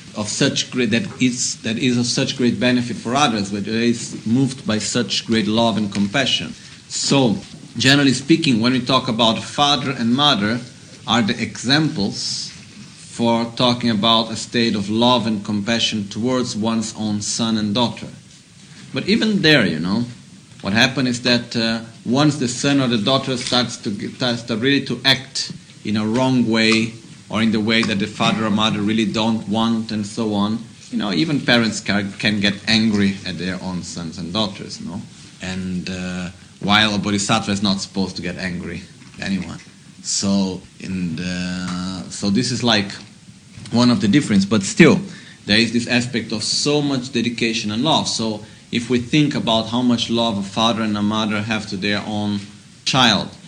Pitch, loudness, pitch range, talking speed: 115 Hz, -18 LUFS, 105-125 Hz, 180 wpm